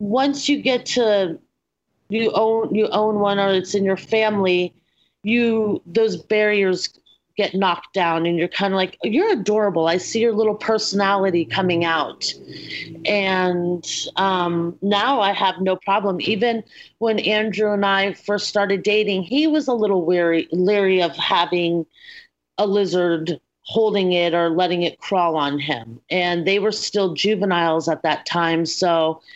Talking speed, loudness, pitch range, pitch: 155 wpm, -20 LUFS, 175-215 Hz, 195 Hz